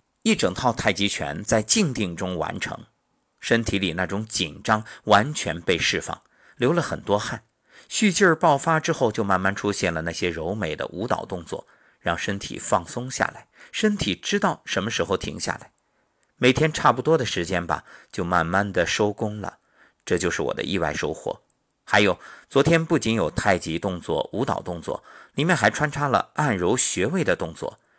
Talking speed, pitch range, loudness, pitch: 260 characters per minute, 95-155 Hz, -23 LUFS, 110 Hz